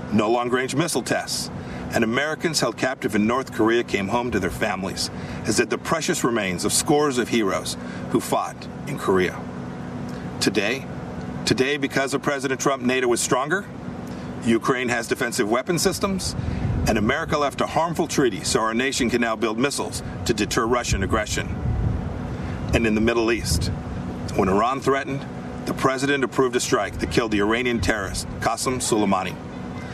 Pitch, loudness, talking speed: 115 Hz, -23 LUFS, 160 wpm